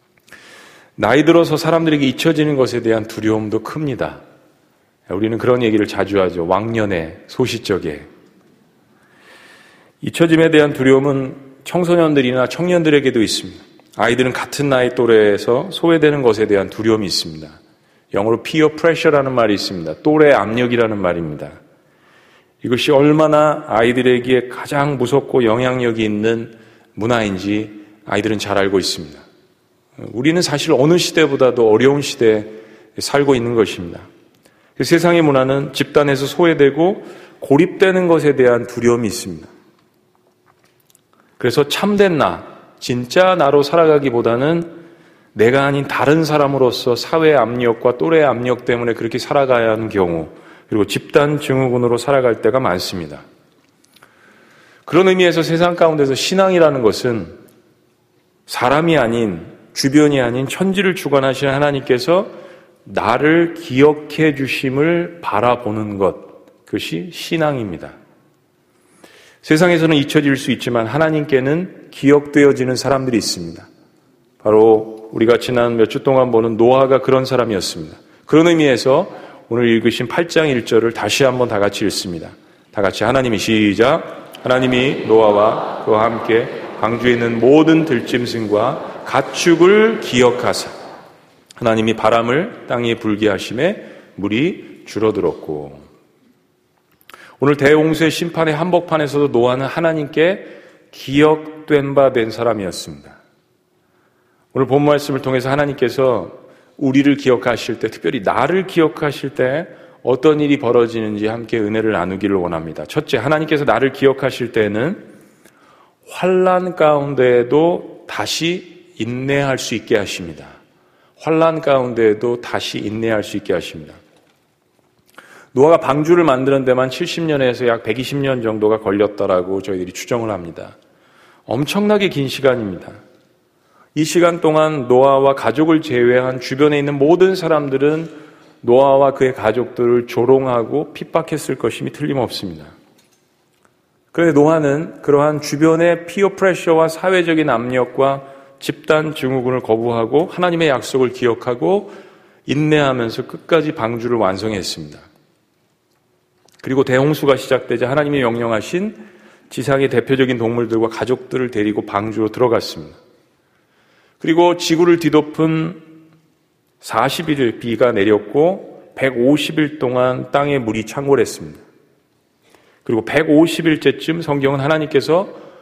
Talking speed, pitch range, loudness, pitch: 305 characters per minute, 115-155 Hz, -15 LUFS, 135 Hz